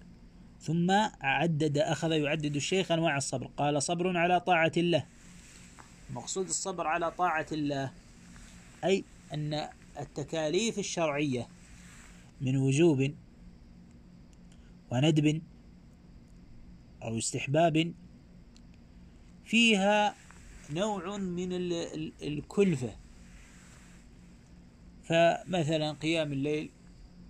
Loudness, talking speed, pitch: -30 LUFS, 75 wpm, 145 Hz